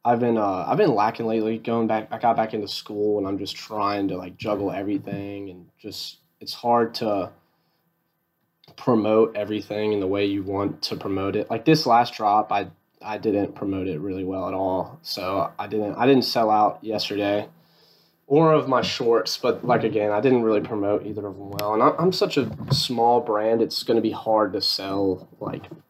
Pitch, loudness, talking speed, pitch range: 105 Hz, -23 LUFS, 205 wpm, 100-115 Hz